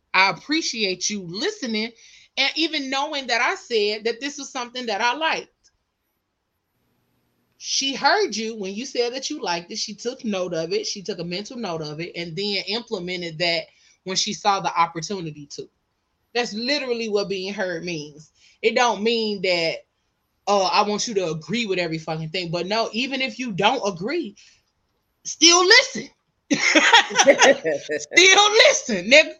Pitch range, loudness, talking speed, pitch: 185-265 Hz, -20 LUFS, 165 wpm, 220 Hz